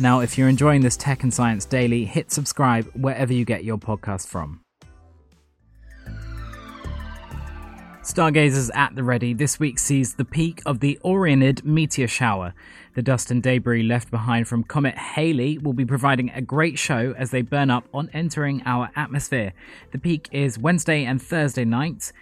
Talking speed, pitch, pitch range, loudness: 165 wpm, 130 Hz, 115-145 Hz, -22 LUFS